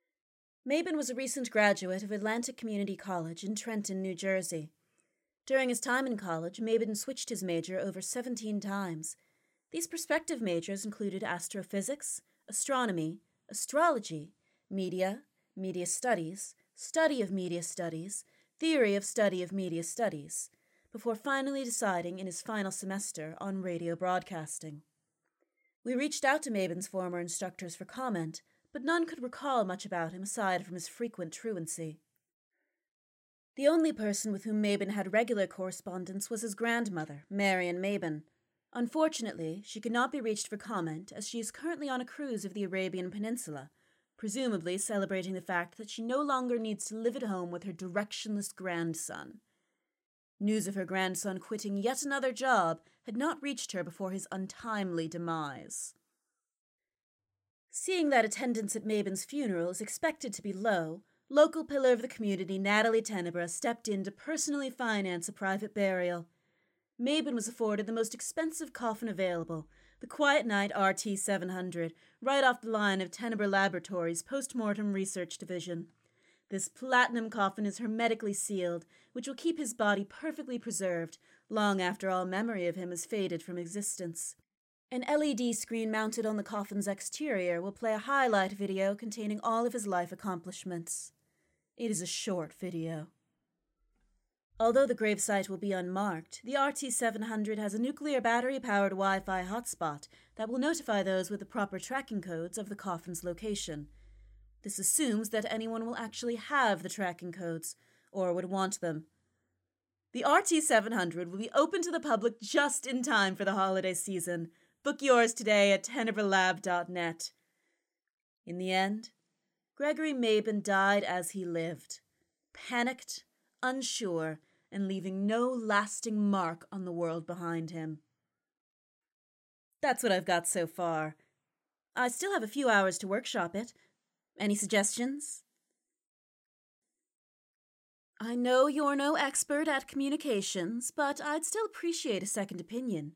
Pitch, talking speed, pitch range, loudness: 200 Hz, 150 wpm, 180-235 Hz, -33 LUFS